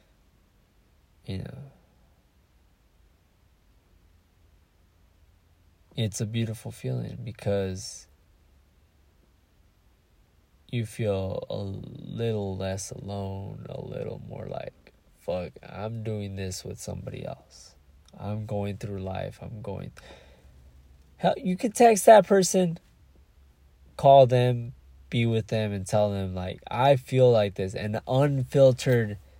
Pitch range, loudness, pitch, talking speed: 80-115 Hz, -26 LUFS, 95 Hz, 105 wpm